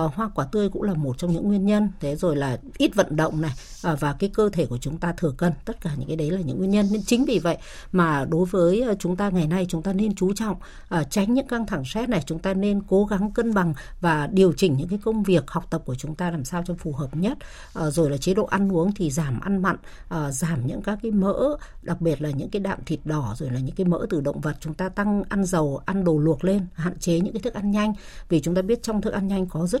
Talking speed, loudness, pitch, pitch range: 280 wpm, -24 LUFS, 180 Hz, 160-205 Hz